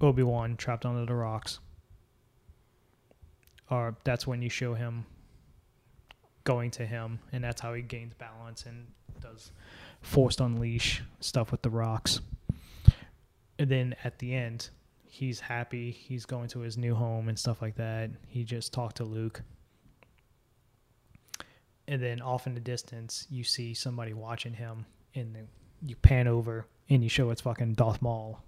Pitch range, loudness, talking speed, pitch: 115-125 Hz, -32 LUFS, 155 wpm, 120 Hz